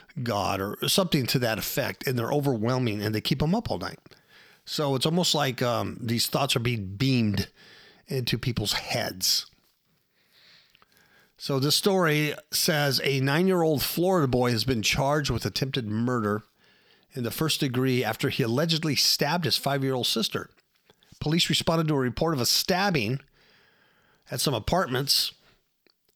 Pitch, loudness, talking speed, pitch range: 135 Hz, -25 LUFS, 160 wpm, 120-155 Hz